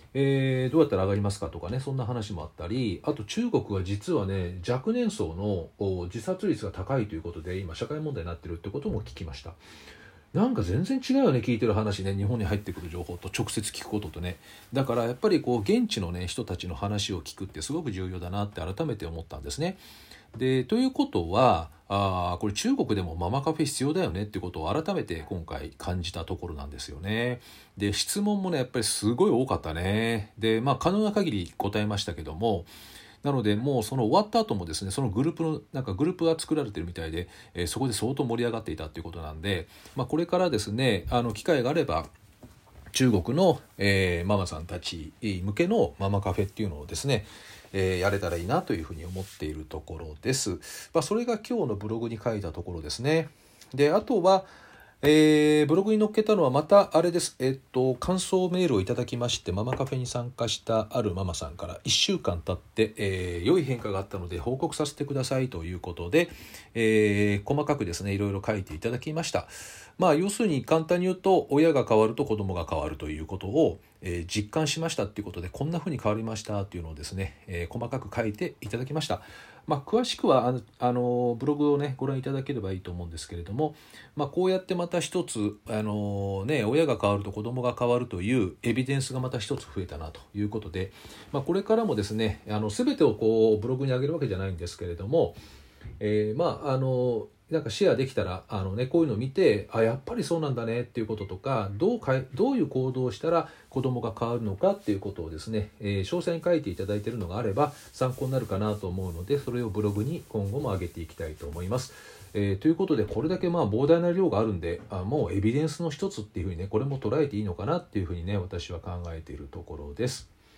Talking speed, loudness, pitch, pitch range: 445 characters per minute, -28 LUFS, 110 Hz, 95-135 Hz